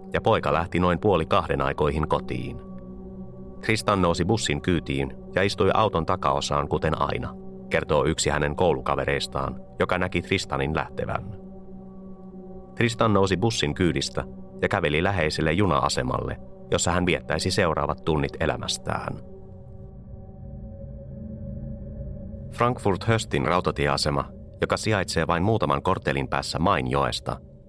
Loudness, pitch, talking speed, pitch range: -24 LUFS, 85 Hz, 105 wpm, 70-100 Hz